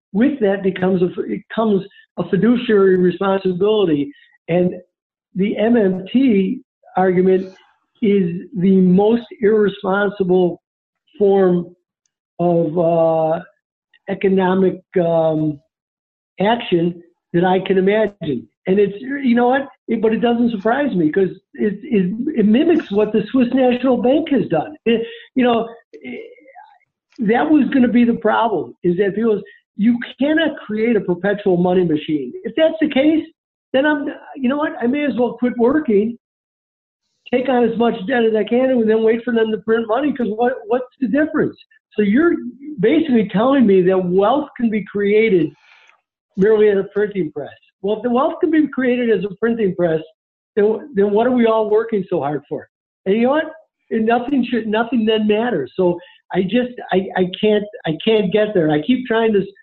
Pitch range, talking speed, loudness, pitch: 190-250 Hz, 170 wpm, -17 LUFS, 215 Hz